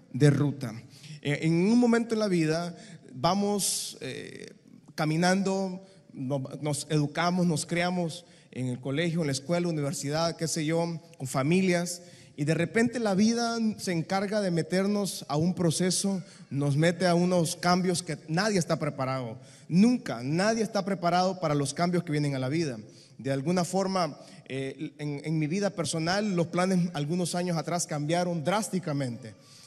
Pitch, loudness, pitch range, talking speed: 170 Hz, -28 LUFS, 150-185 Hz, 155 wpm